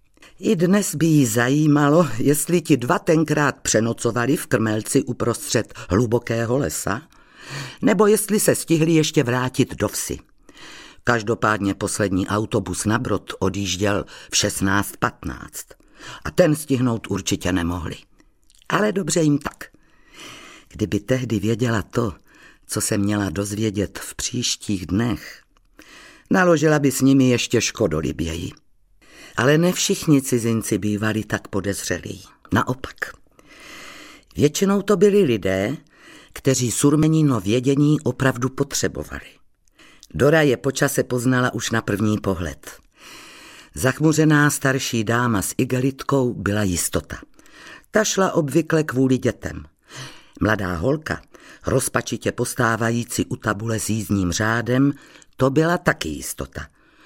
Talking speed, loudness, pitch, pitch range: 115 wpm, -20 LUFS, 125 Hz, 105-145 Hz